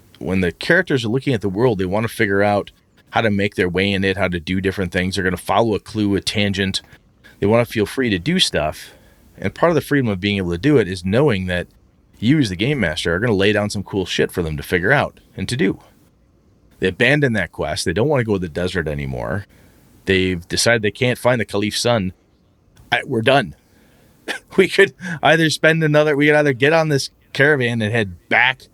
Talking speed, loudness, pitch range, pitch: 240 wpm, -18 LUFS, 95-135 Hz, 105 Hz